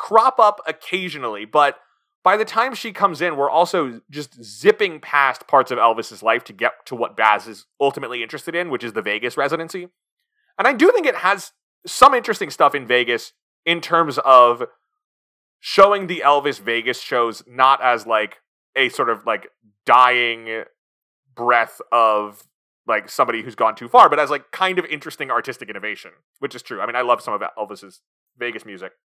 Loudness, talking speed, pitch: -18 LUFS, 180 wpm, 160 Hz